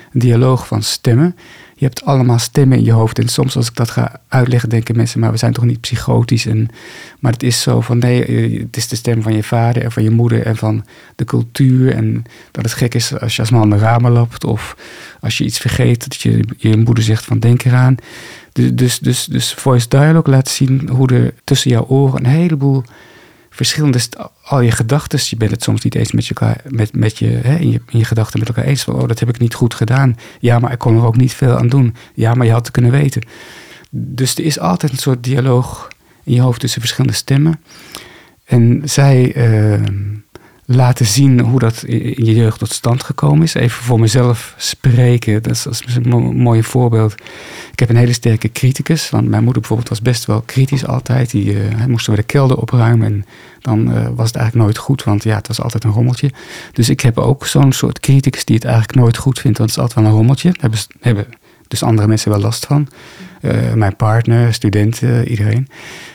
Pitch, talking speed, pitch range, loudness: 120 Hz, 225 wpm, 115-130 Hz, -13 LUFS